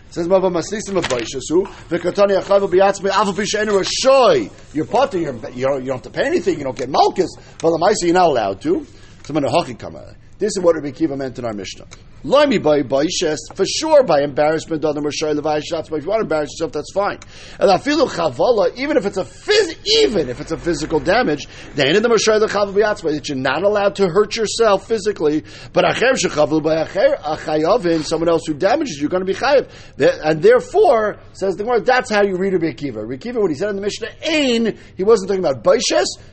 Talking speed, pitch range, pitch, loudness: 205 wpm, 155-220 Hz, 185 Hz, -17 LUFS